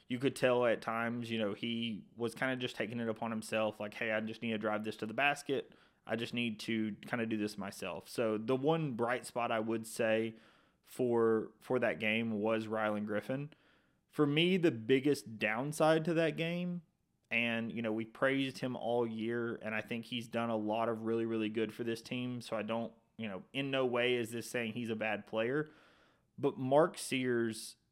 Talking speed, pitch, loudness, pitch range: 215 wpm, 115 Hz, -35 LUFS, 110-130 Hz